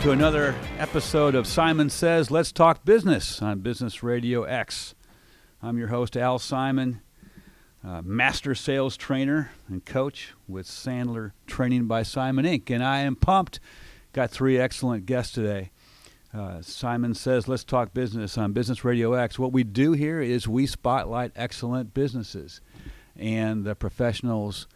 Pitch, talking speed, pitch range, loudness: 125 Hz, 150 wpm, 115-135 Hz, -25 LUFS